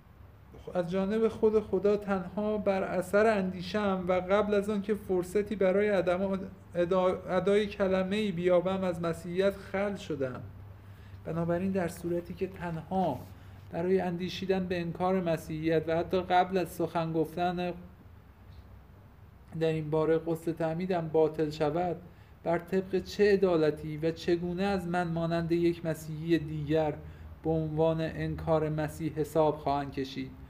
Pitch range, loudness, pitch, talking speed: 155-190 Hz, -30 LUFS, 175 Hz, 130 wpm